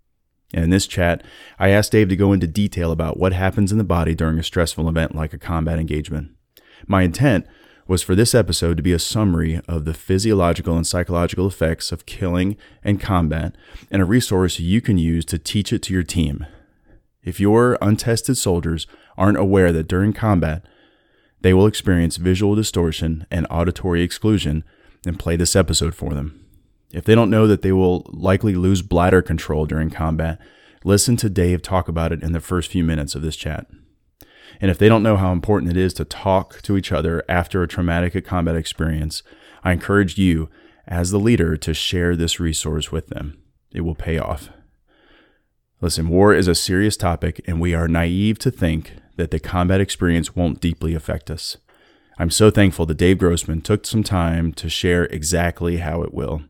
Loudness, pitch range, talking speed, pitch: -19 LUFS, 80-95 Hz, 190 wpm, 85 Hz